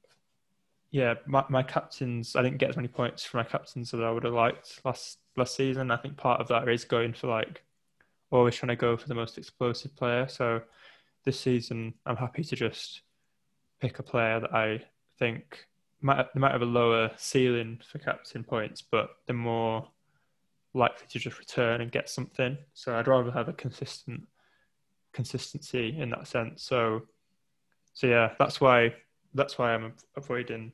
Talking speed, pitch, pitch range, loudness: 180 wpm, 125 Hz, 115-135 Hz, -29 LUFS